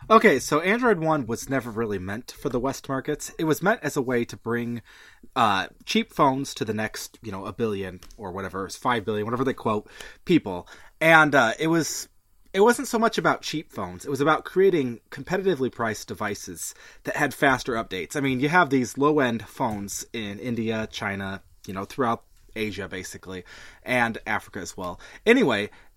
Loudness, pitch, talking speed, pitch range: -24 LUFS, 120 Hz, 185 wpm, 105-150 Hz